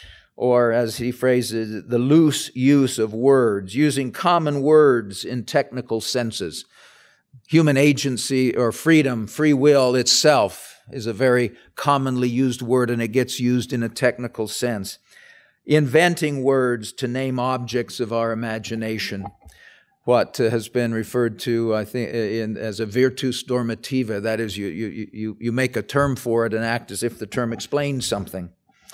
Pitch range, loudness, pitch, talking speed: 115-130 Hz, -21 LUFS, 125 Hz, 155 wpm